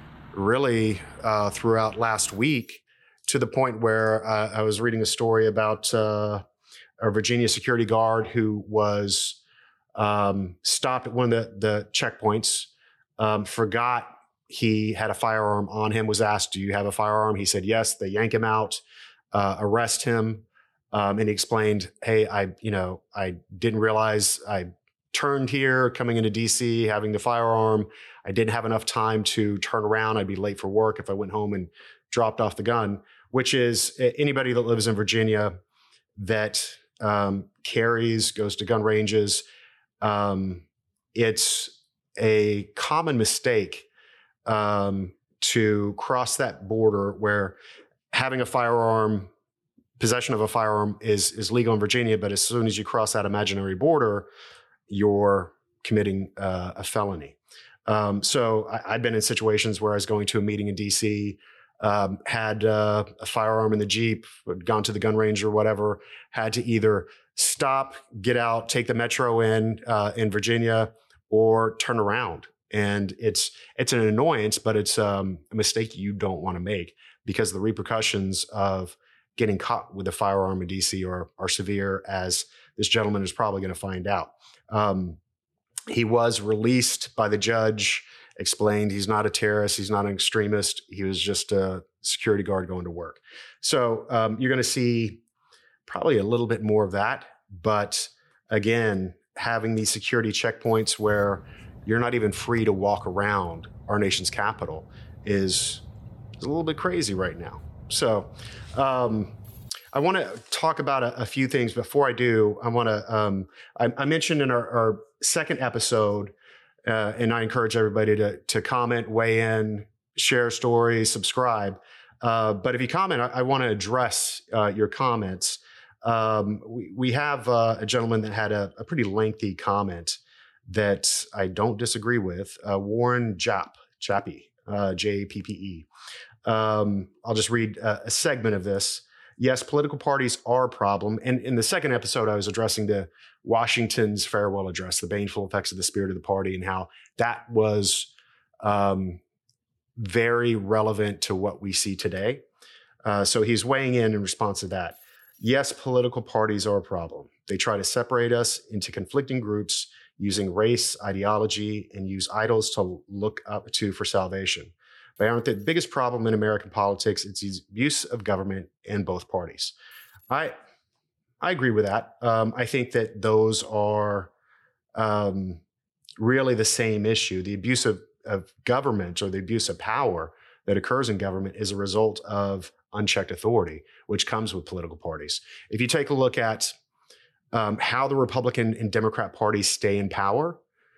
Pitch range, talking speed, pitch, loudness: 100-115 Hz, 165 wpm, 110 Hz, -25 LUFS